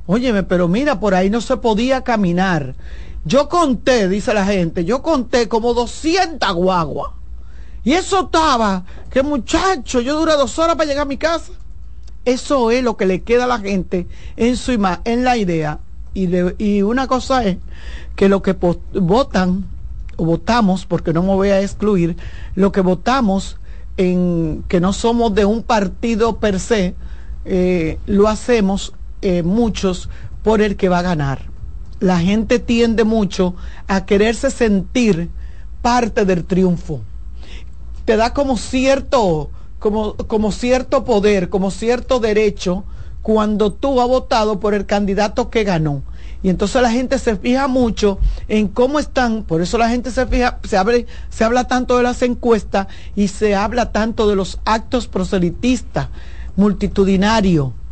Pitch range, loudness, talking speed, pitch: 185-245 Hz, -17 LUFS, 160 wpm, 215 Hz